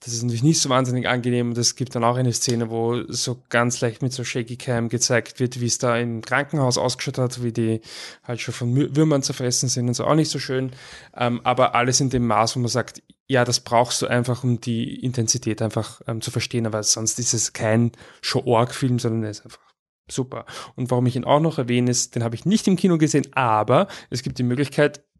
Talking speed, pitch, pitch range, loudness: 230 wpm, 125 Hz, 115-130 Hz, -22 LUFS